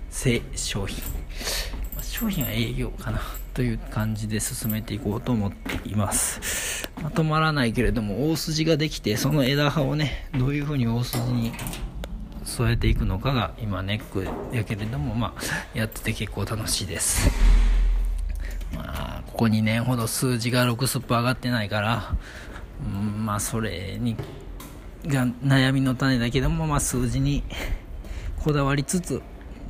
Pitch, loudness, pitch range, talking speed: 115 Hz, -25 LUFS, 100-130 Hz, 285 characters per minute